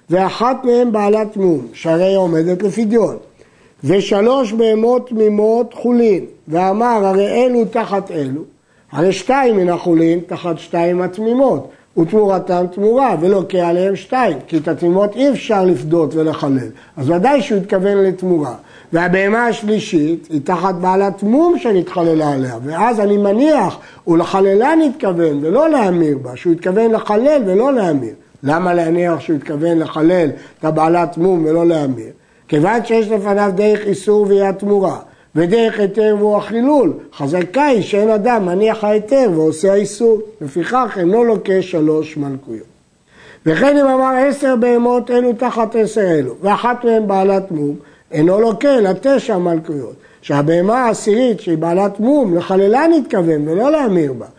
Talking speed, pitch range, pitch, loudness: 140 wpm, 170-225 Hz, 195 Hz, -14 LUFS